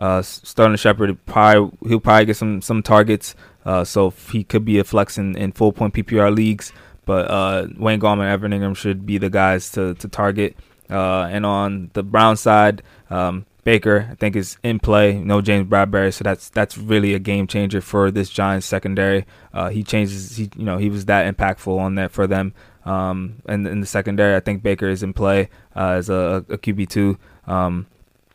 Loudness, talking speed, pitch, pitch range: -18 LUFS, 205 wpm, 100 Hz, 95-105 Hz